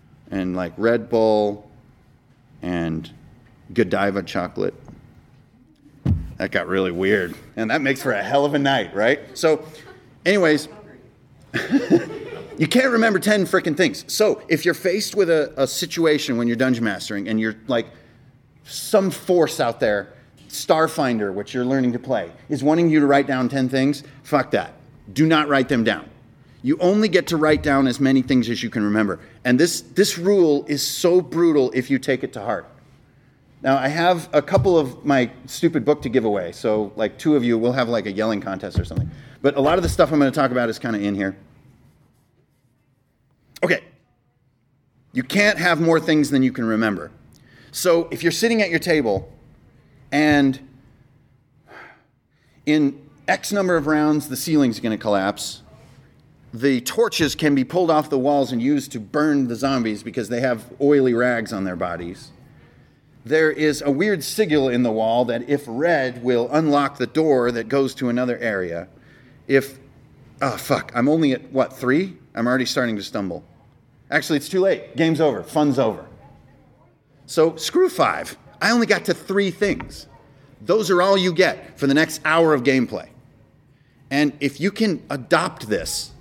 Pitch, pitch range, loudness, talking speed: 135 Hz, 120-155 Hz, -20 LUFS, 175 wpm